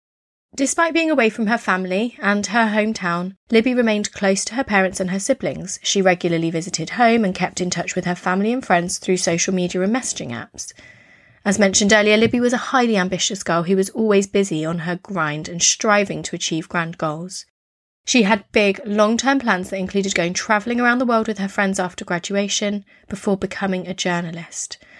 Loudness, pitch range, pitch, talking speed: -19 LUFS, 180-220 Hz, 195 Hz, 195 wpm